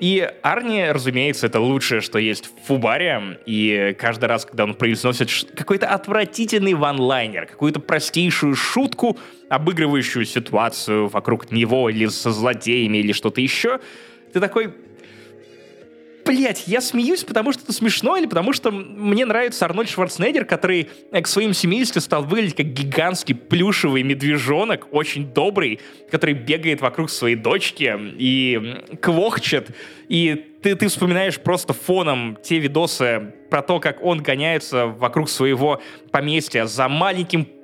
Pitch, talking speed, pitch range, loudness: 150 Hz, 135 wpm, 120-185 Hz, -19 LUFS